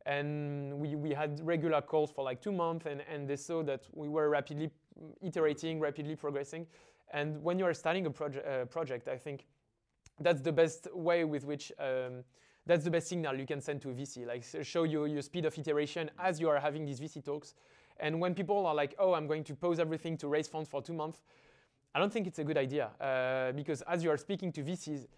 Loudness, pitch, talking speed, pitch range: -36 LUFS, 150 Hz, 230 wpm, 145-165 Hz